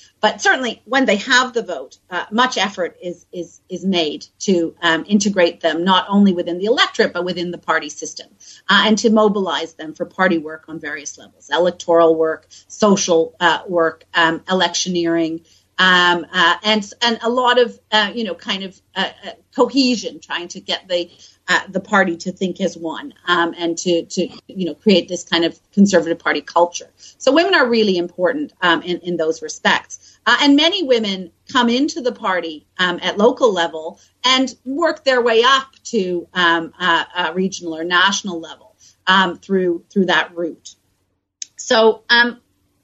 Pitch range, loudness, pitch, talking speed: 170-220 Hz, -17 LUFS, 180 Hz, 180 wpm